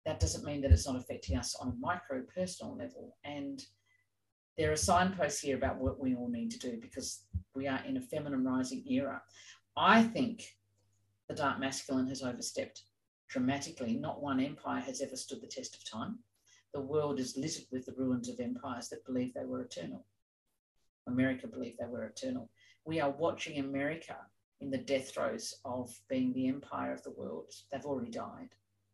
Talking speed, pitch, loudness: 180 wpm, 140 Hz, -36 LUFS